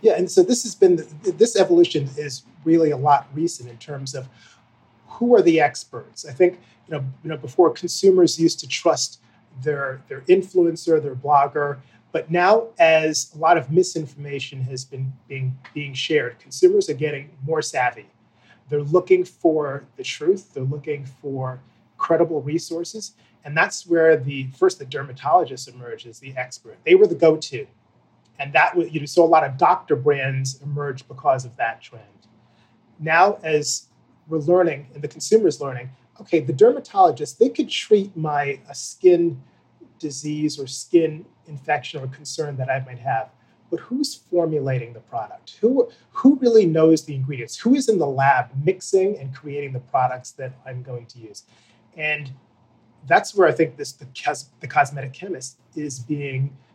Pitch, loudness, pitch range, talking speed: 150 Hz, -20 LUFS, 130-170 Hz, 165 wpm